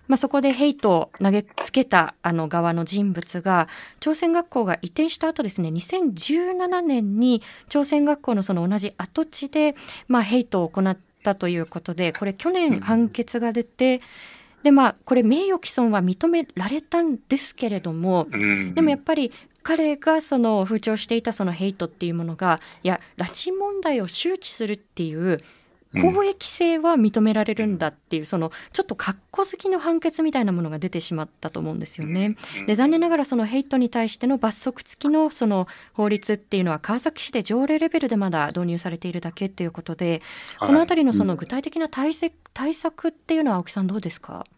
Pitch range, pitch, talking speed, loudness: 180-300 Hz, 230 Hz, 370 characters per minute, -23 LUFS